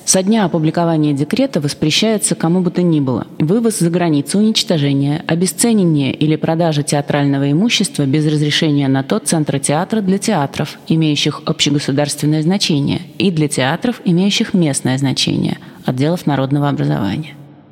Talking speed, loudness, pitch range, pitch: 130 wpm, -15 LUFS, 145-180 Hz, 155 Hz